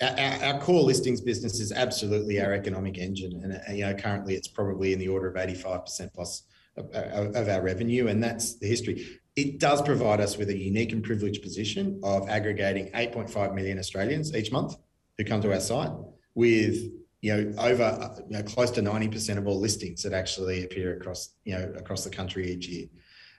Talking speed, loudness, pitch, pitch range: 200 wpm, -28 LUFS, 100 Hz, 95-115 Hz